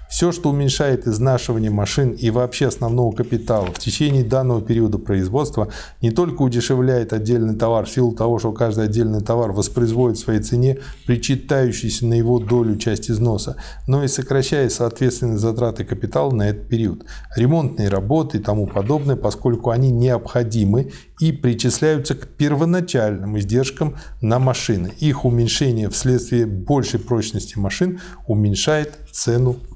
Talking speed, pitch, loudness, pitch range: 135 wpm, 120 Hz, -19 LUFS, 110-135 Hz